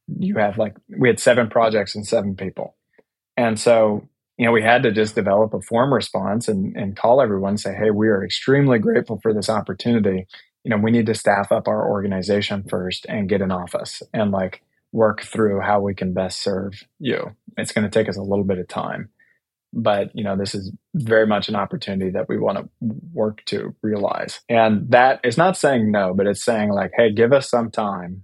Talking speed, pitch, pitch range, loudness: 215 wpm, 105 Hz, 100-115 Hz, -20 LUFS